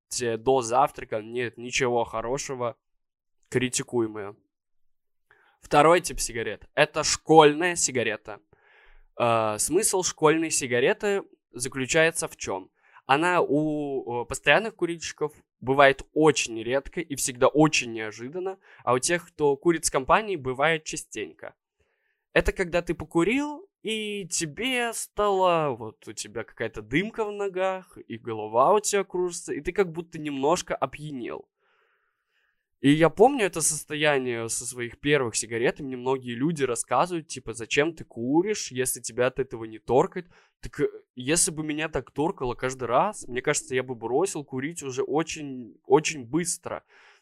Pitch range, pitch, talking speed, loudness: 130-180 Hz, 150 Hz, 130 wpm, -25 LUFS